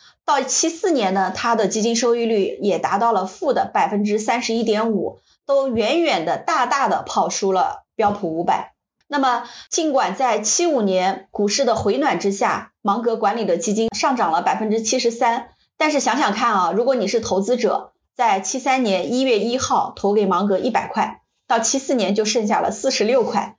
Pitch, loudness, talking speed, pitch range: 230 Hz, -19 LUFS, 280 characters per minute, 205-265 Hz